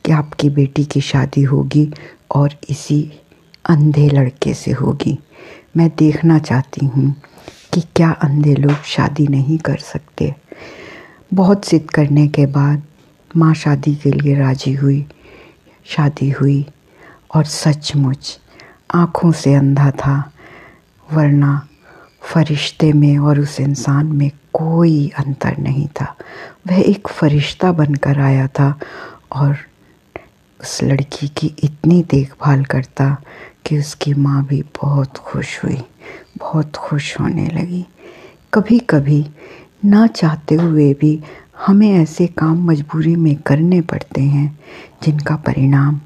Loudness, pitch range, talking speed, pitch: -15 LUFS, 140-160 Hz, 120 wpm, 150 Hz